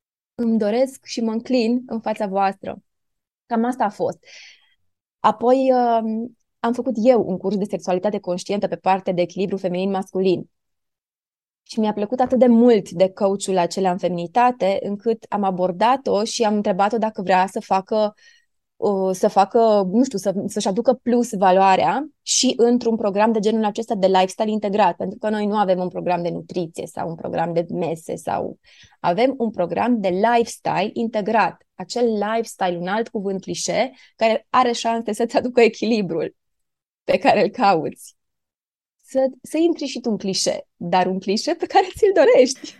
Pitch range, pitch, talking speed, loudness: 190-240 Hz, 215 Hz, 165 wpm, -20 LUFS